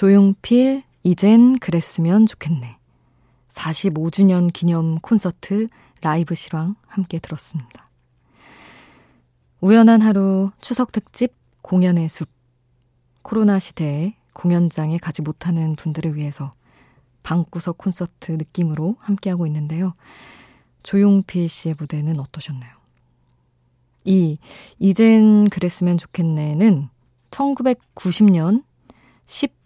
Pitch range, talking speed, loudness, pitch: 150-195 Hz, 220 characters per minute, -18 LUFS, 170 Hz